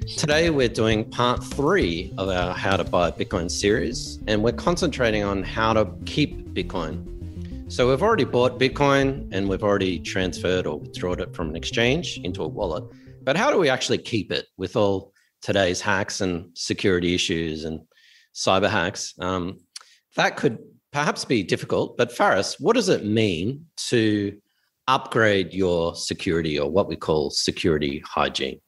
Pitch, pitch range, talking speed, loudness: 100 Hz, 90-115 Hz, 160 wpm, -23 LUFS